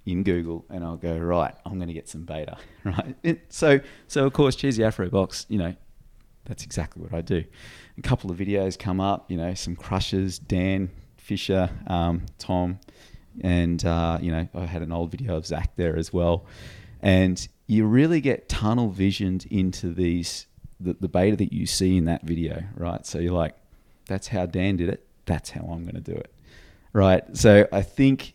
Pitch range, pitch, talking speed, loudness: 85-105 Hz, 95 Hz, 195 wpm, -25 LUFS